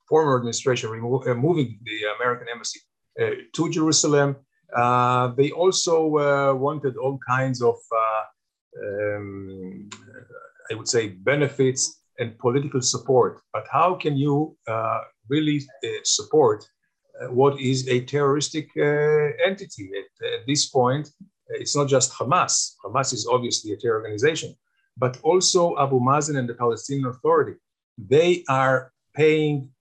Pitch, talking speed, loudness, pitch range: 140 Hz, 135 wpm, -22 LUFS, 125-170 Hz